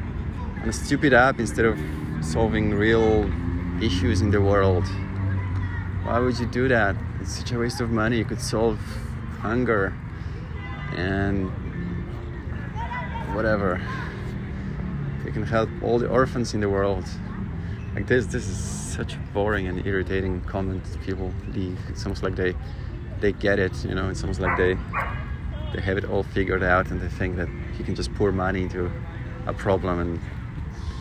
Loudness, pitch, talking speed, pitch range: -25 LUFS, 95 Hz, 155 wpm, 90-105 Hz